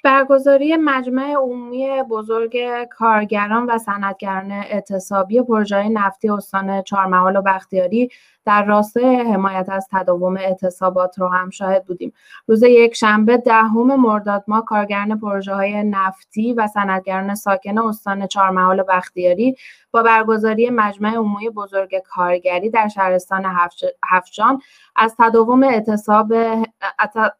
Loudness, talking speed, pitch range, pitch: -17 LUFS, 115 wpm, 195-230 Hz, 210 Hz